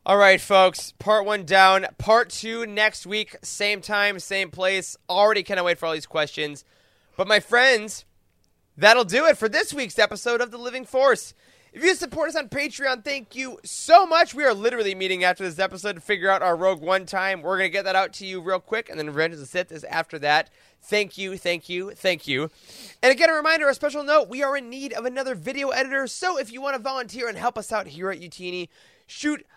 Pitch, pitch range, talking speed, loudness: 210 Hz, 185-260 Hz, 230 wpm, -22 LUFS